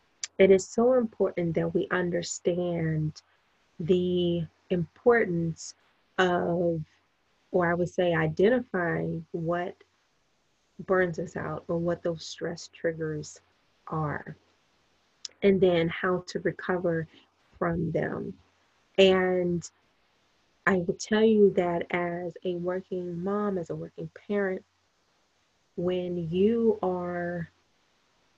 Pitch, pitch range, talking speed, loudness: 180 Hz, 170-190 Hz, 105 wpm, -28 LUFS